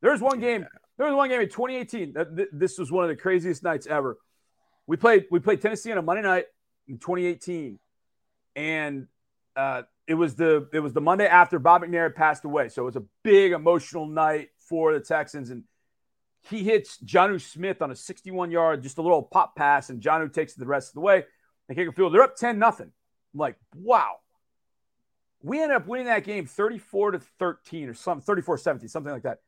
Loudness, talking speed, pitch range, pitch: -24 LUFS, 205 wpm, 155-200 Hz, 175 Hz